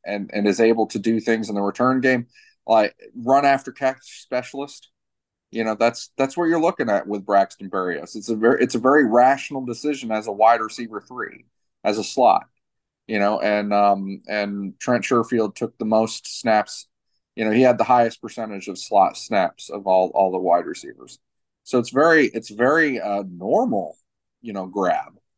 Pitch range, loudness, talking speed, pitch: 100-125 Hz, -20 LUFS, 190 wpm, 115 Hz